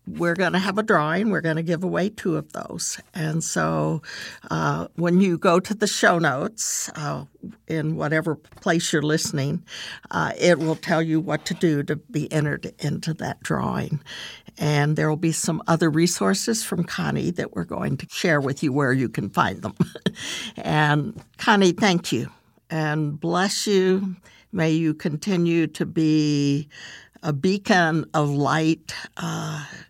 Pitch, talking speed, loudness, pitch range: 160 Hz, 165 wpm, -23 LUFS, 150-180 Hz